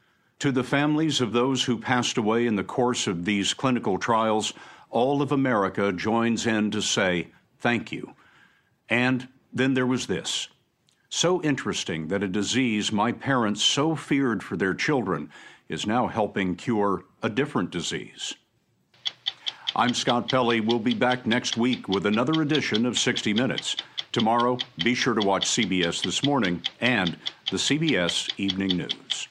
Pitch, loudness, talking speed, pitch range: 120 Hz, -25 LUFS, 155 wpm, 105-130 Hz